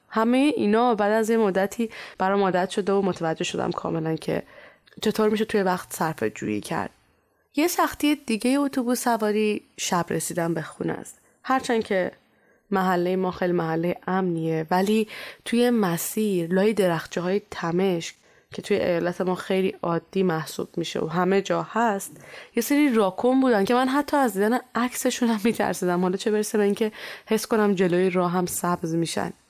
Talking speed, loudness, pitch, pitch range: 165 wpm, -24 LUFS, 195 Hz, 180-225 Hz